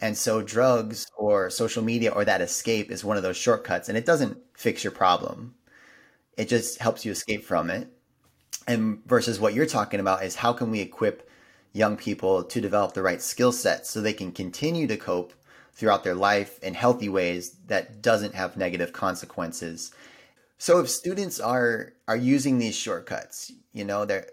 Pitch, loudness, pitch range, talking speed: 110 Hz, -26 LUFS, 100-125 Hz, 185 wpm